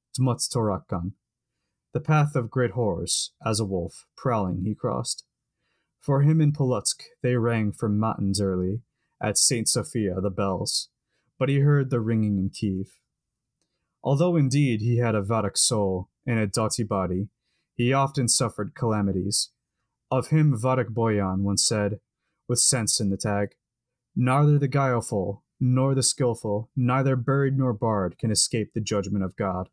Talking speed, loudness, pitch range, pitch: 150 wpm, -24 LUFS, 100-130 Hz, 120 Hz